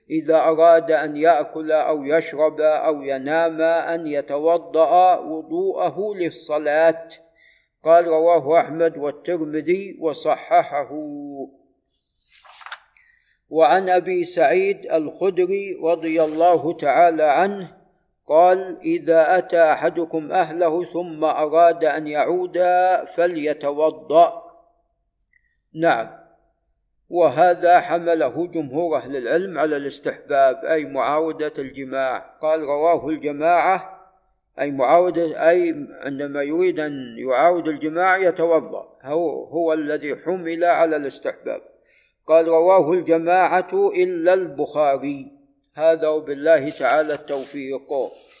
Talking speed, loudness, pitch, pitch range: 90 wpm, -19 LUFS, 165 Hz, 155-180 Hz